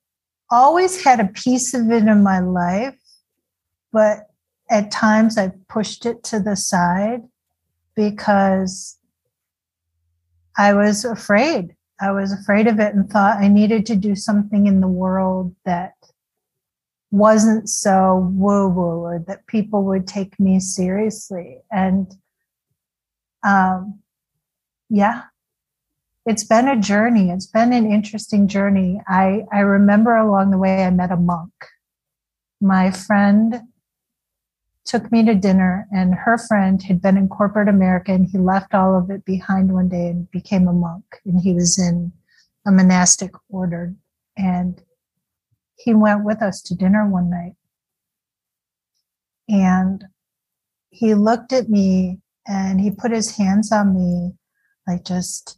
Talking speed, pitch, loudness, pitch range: 135 wpm, 195 Hz, -17 LUFS, 185-215 Hz